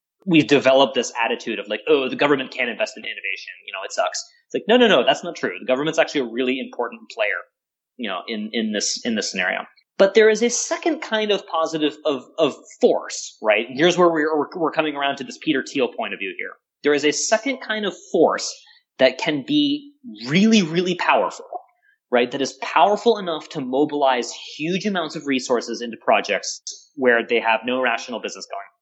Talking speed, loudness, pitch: 210 wpm, -21 LUFS, 165 Hz